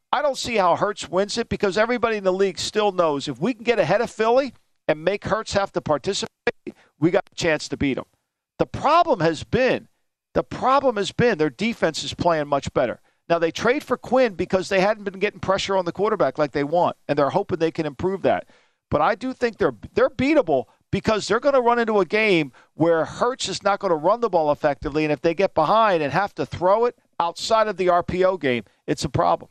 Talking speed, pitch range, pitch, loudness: 235 wpm, 165-220 Hz, 190 Hz, -22 LUFS